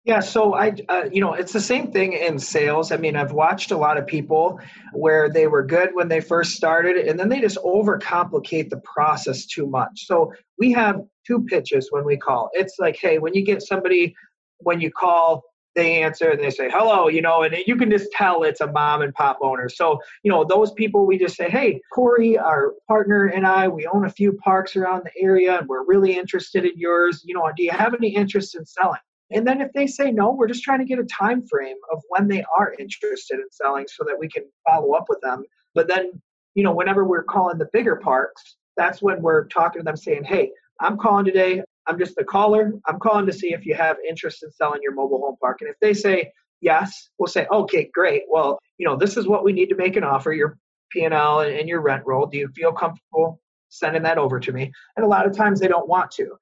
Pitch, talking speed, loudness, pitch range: 190 Hz, 240 wpm, -20 LUFS, 165-230 Hz